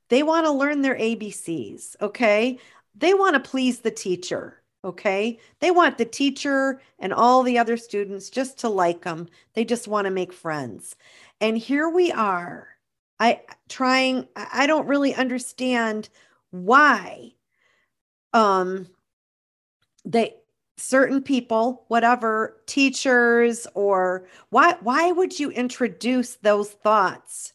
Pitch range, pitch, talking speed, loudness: 205-265 Hz, 235 Hz, 125 wpm, -22 LUFS